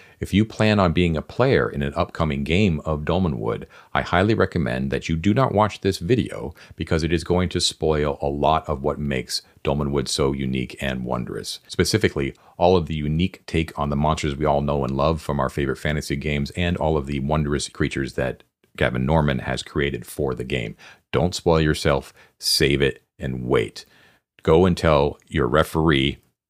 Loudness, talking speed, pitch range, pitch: -22 LUFS, 190 wpm, 70-85 Hz, 75 Hz